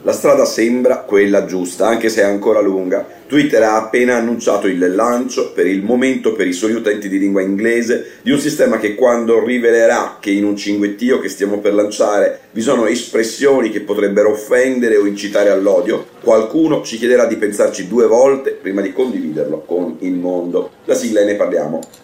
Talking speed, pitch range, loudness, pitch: 180 wpm, 100-125 Hz, -15 LUFS, 110 Hz